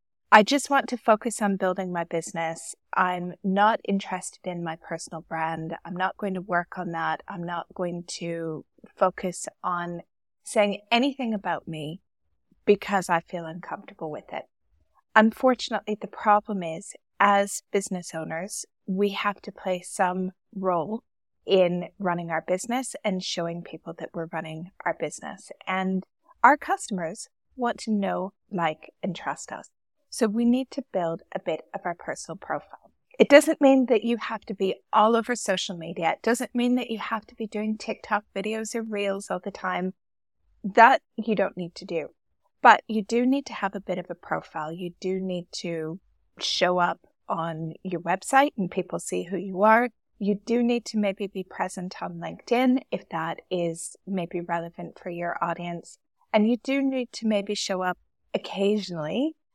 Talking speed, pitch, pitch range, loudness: 170 wpm, 190 Hz, 175-220 Hz, -26 LUFS